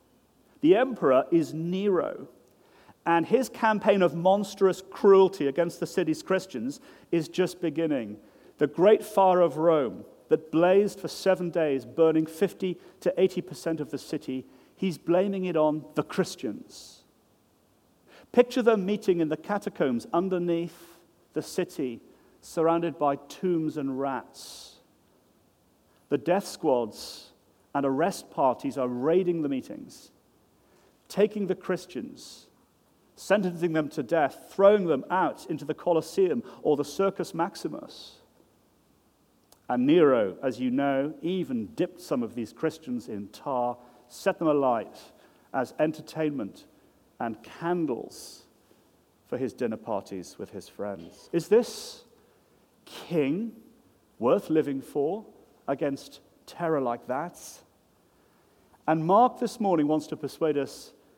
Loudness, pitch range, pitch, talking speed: -27 LUFS, 150-195 Hz, 170 Hz, 125 wpm